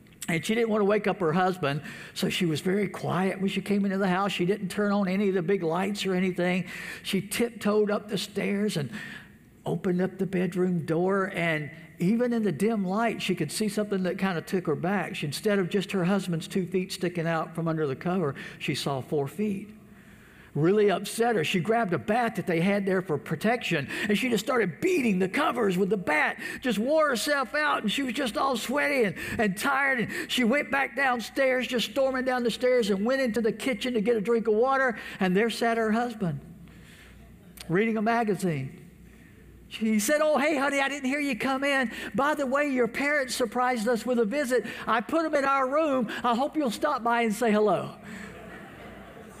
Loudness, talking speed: -27 LUFS, 215 wpm